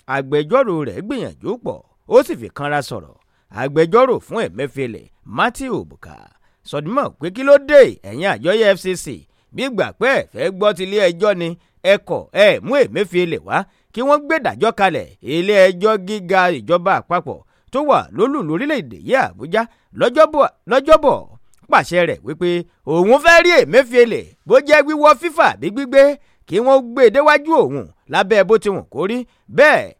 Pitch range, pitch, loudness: 175-285 Hz, 215 Hz, -15 LUFS